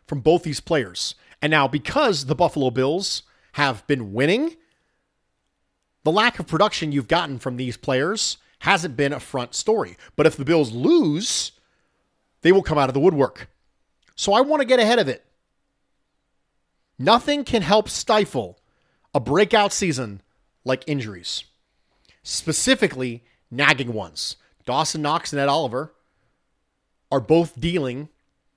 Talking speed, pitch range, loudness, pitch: 140 wpm, 130-185 Hz, -21 LUFS, 150 Hz